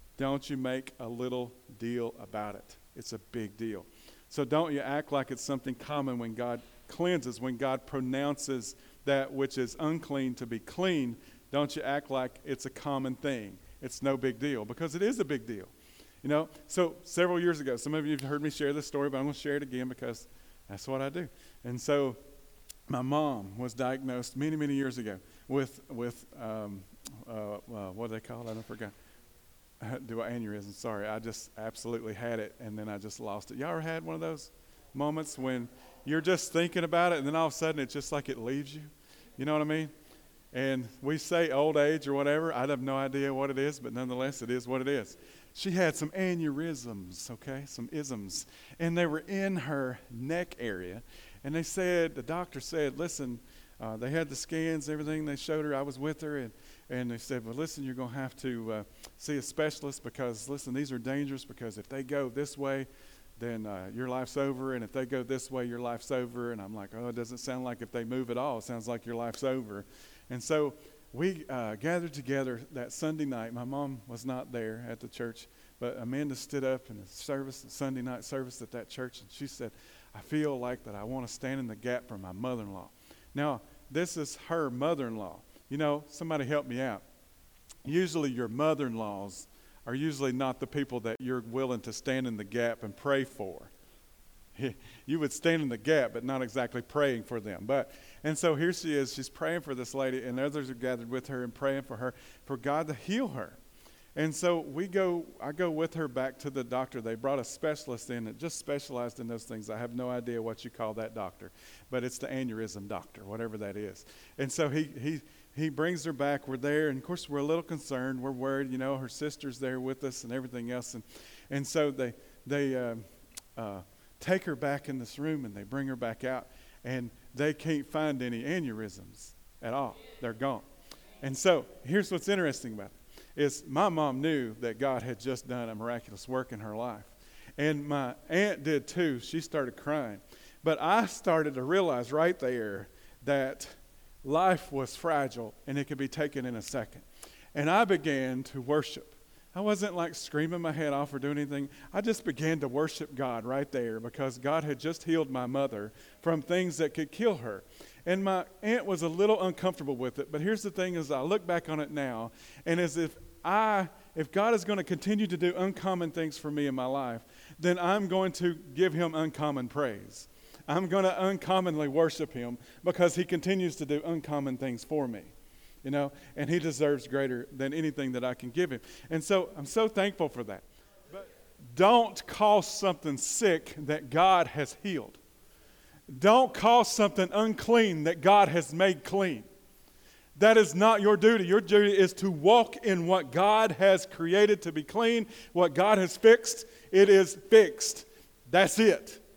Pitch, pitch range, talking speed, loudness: 140 Hz, 125-160 Hz, 205 wpm, -32 LUFS